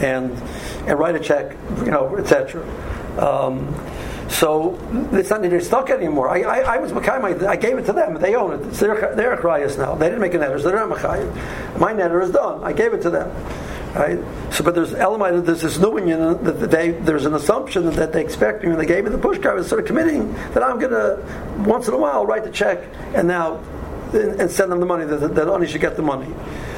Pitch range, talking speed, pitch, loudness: 160-195 Hz, 225 wpm, 175 Hz, -19 LUFS